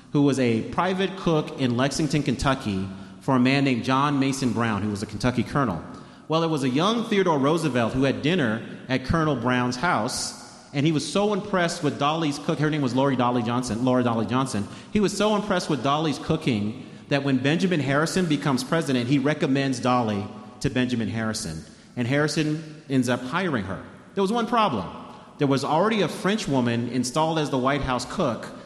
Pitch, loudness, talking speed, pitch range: 140 Hz, -24 LUFS, 195 wpm, 125-160 Hz